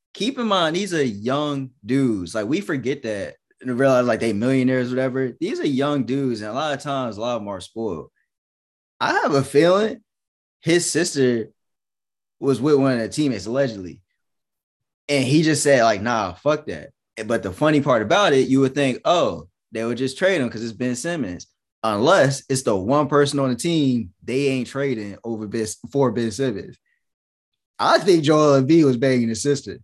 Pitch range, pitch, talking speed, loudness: 115-145 Hz, 135 Hz, 195 wpm, -20 LUFS